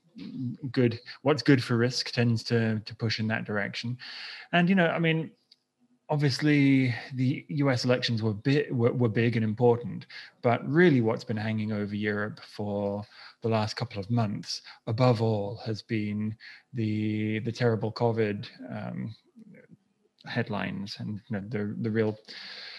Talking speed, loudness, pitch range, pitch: 150 wpm, -28 LUFS, 110-135 Hz, 115 Hz